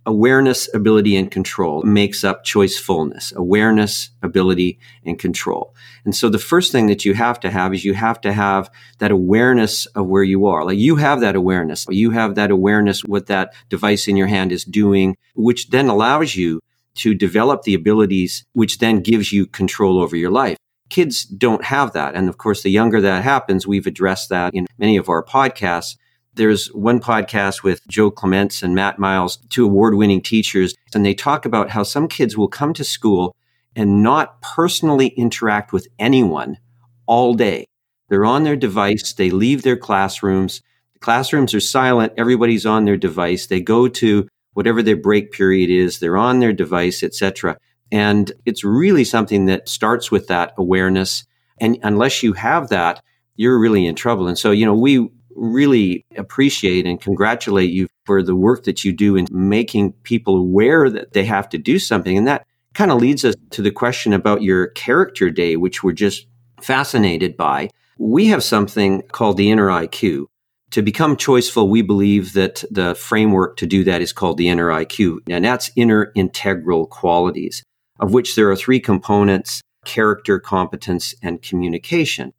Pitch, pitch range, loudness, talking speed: 105 Hz, 95-120 Hz, -16 LUFS, 180 wpm